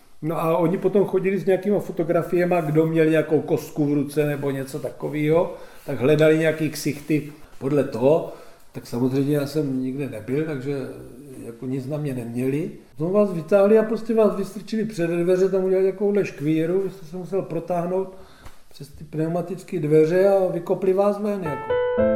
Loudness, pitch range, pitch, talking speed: -22 LUFS, 145-190 Hz, 165 Hz, 170 wpm